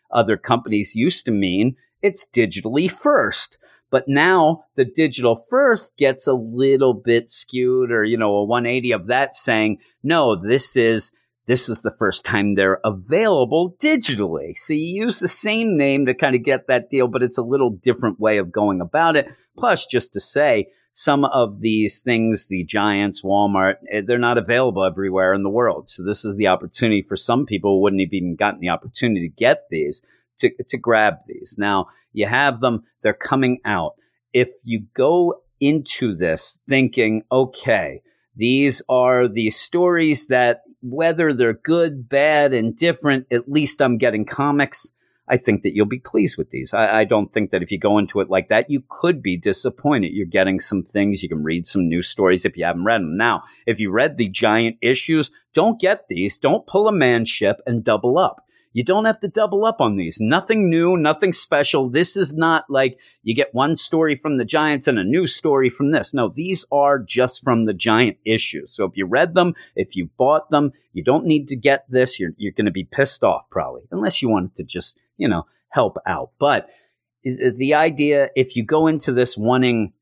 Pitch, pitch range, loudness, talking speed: 125 Hz, 110-150 Hz, -19 LUFS, 200 wpm